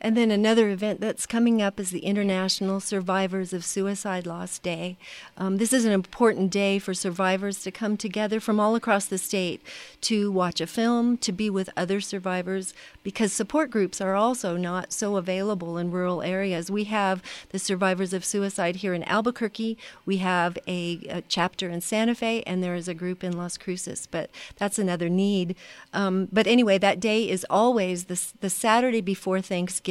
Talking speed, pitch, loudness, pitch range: 185 wpm, 195 Hz, -26 LUFS, 185-215 Hz